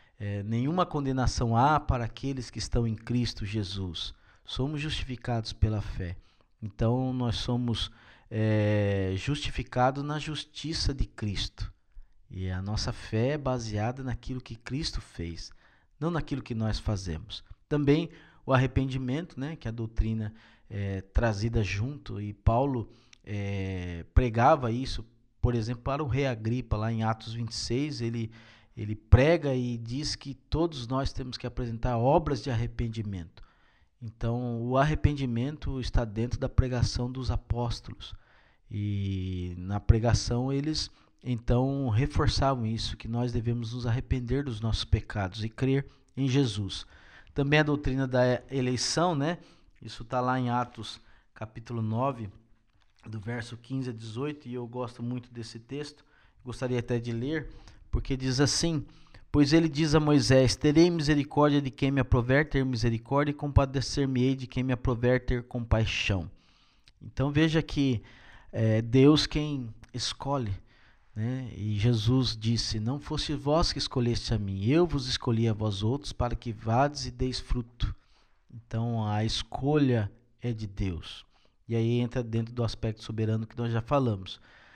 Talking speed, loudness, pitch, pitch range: 145 wpm, -29 LUFS, 120 Hz, 110-135 Hz